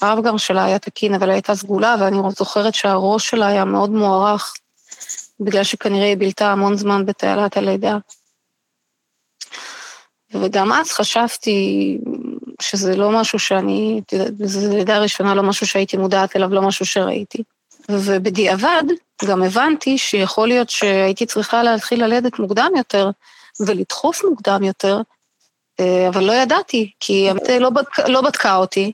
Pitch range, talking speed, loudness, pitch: 195-235 Hz, 135 wpm, -17 LUFS, 205 Hz